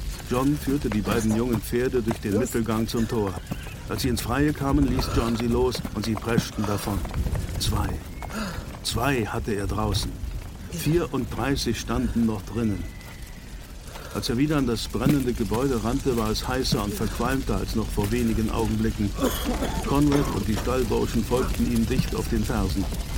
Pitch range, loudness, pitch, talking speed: 105-125 Hz, -26 LUFS, 115 Hz, 160 wpm